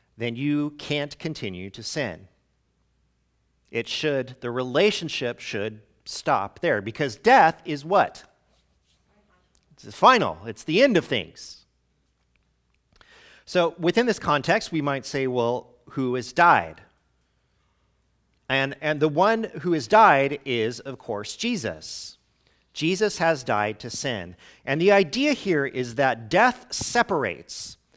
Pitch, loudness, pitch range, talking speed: 135 Hz, -23 LUFS, 105-160 Hz, 130 wpm